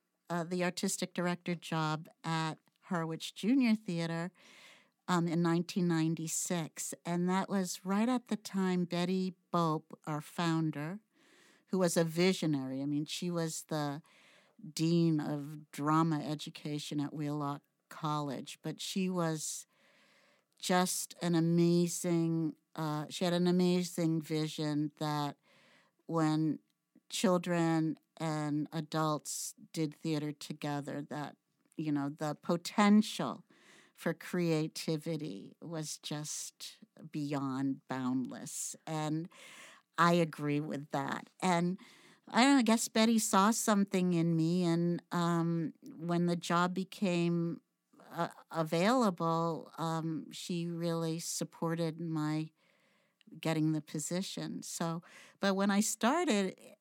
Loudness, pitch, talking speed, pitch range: -34 LUFS, 170 Hz, 110 wpm, 155-185 Hz